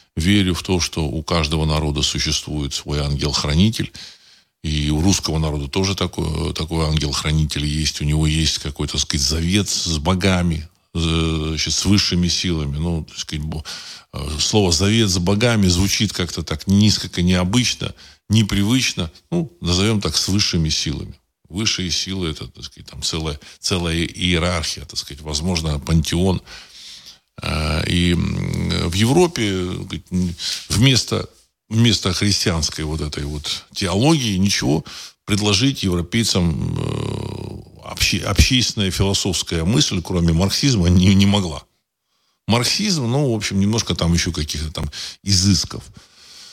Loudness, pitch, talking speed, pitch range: -19 LUFS, 90 Hz, 125 wpm, 80-100 Hz